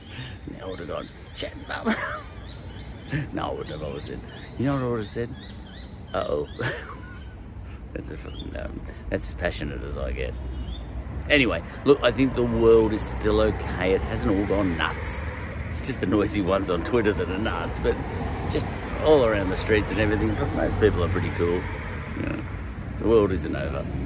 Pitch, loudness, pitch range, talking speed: 95 Hz, -26 LUFS, 85-110 Hz, 175 wpm